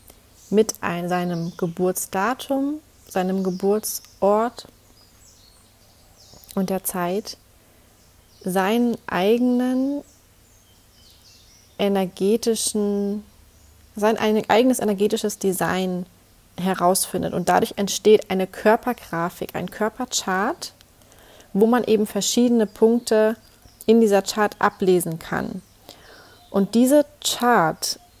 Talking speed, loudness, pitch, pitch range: 80 wpm, -21 LUFS, 195 Hz, 170-220 Hz